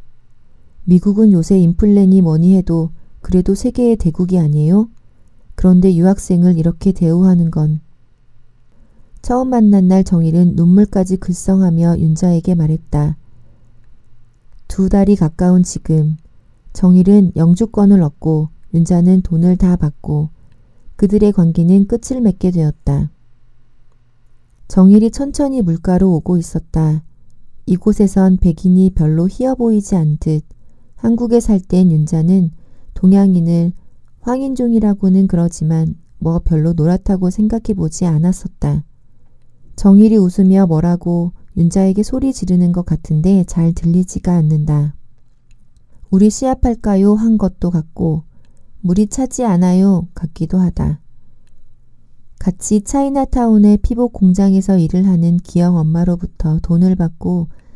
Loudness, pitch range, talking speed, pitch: -13 LUFS, 160-195 Hz, 265 characters per minute, 180 Hz